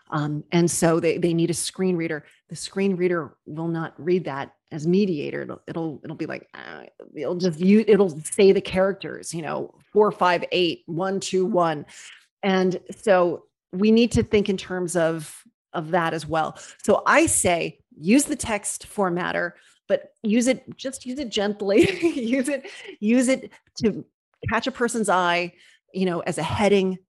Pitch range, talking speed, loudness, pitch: 165-210 Hz, 170 wpm, -23 LUFS, 185 Hz